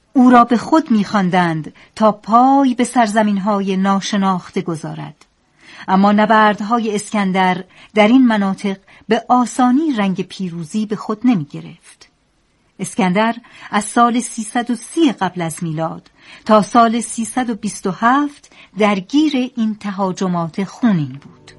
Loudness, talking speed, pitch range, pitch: -16 LUFS, 115 wpm, 190-240 Hz, 215 Hz